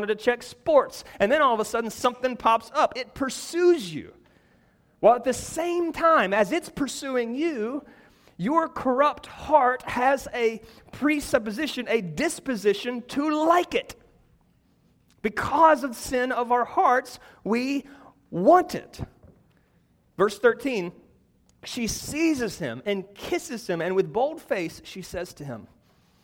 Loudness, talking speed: -24 LUFS, 135 wpm